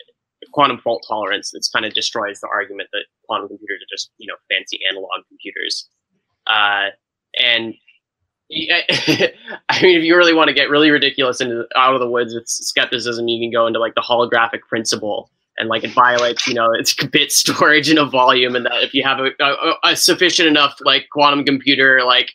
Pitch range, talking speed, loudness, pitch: 125-155 Hz, 190 wpm, -15 LUFS, 135 Hz